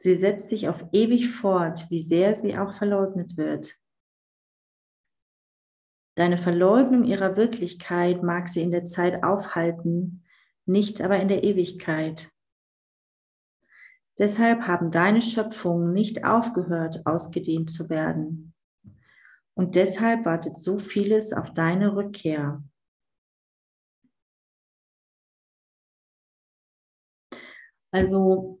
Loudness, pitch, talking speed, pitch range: -24 LUFS, 180 Hz, 95 wpm, 165-200 Hz